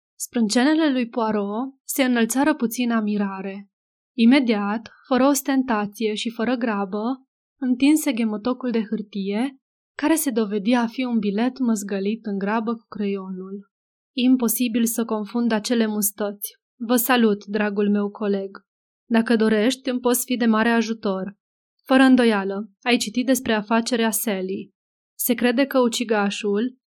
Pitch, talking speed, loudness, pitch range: 230 Hz, 130 wpm, -22 LUFS, 210-250 Hz